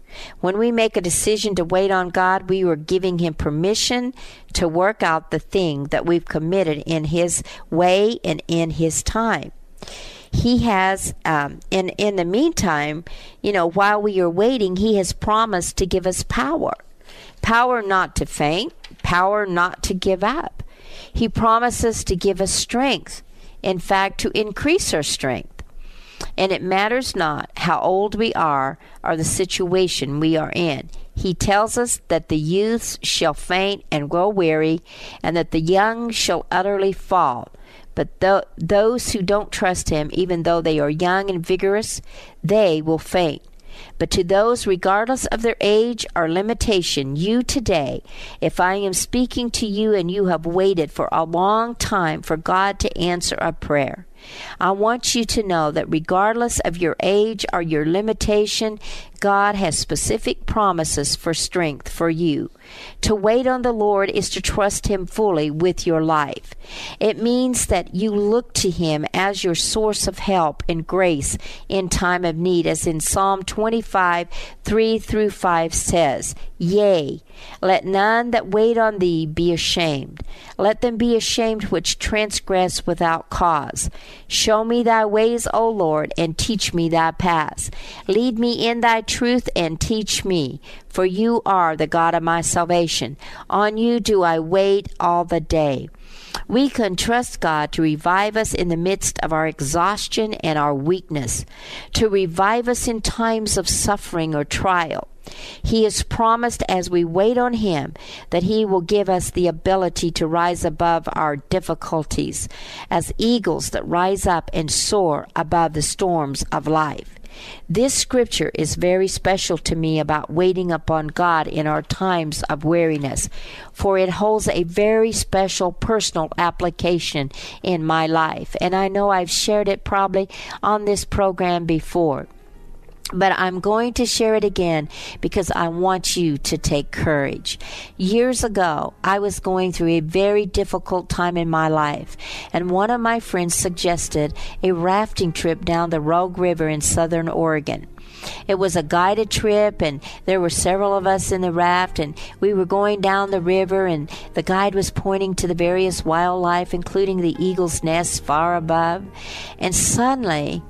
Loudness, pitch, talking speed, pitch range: -20 LUFS, 185 Hz, 165 wpm, 165-210 Hz